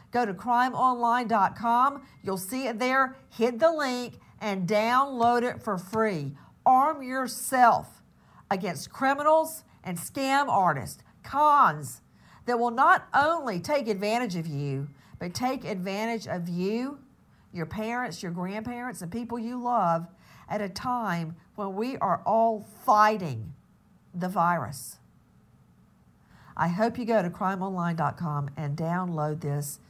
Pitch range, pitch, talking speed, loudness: 175-250 Hz, 220 Hz, 125 wpm, -27 LUFS